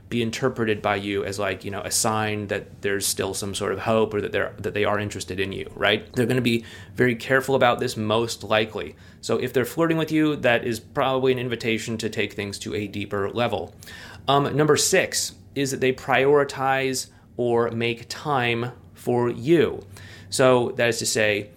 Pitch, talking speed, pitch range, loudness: 115 Hz, 200 wpm, 105-125 Hz, -23 LUFS